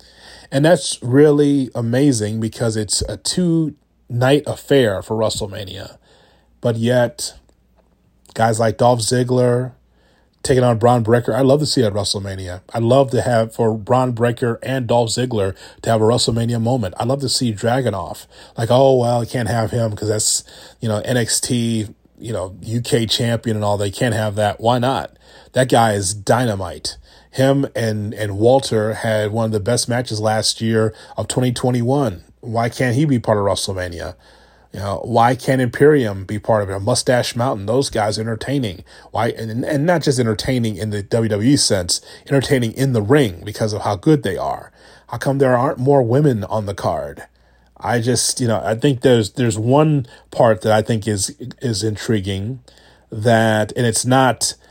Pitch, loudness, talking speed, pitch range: 115 Hz, -18 LUFS, 180 wpm, 110-130 Hz